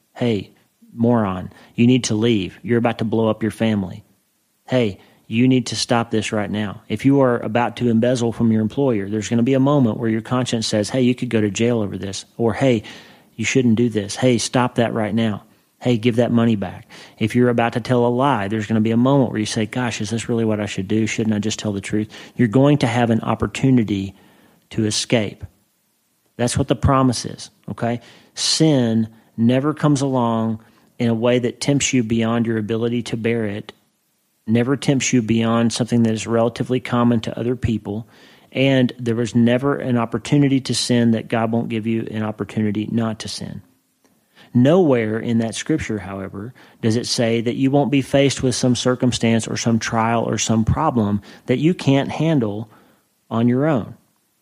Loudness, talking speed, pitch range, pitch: -19 LUFS, 200 wpm, 110-125 Hz, 115 Hz